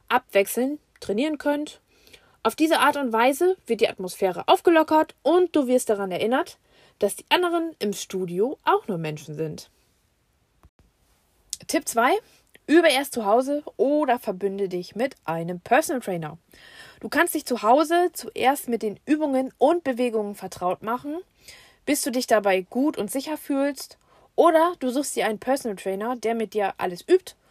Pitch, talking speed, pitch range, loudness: 255 Hz, 155 wpm, 205-305 Hz, -23 LUFS